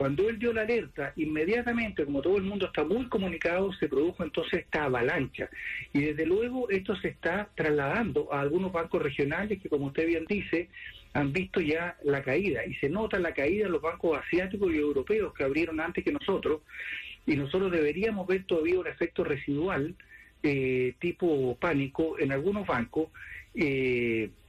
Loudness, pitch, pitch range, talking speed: -30 LUFS, 165 Hz, 145-200 Hz, 170 wpm